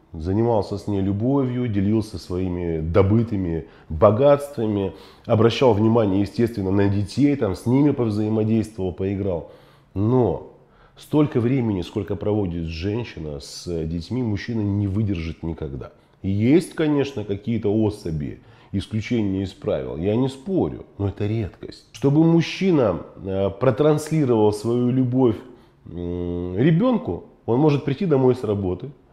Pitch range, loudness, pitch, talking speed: 95-125 Hz, -22 LUFS, 105 Hz, 115 wpm